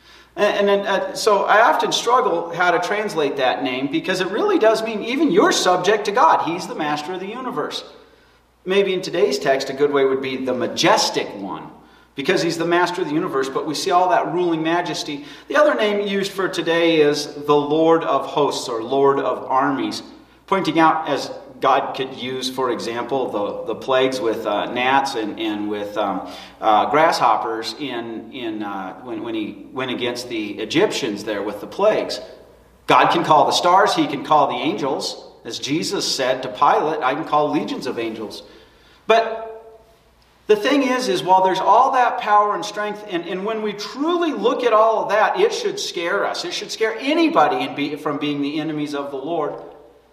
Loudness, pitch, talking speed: -19 LUFS, 195 Hz, 195 wpm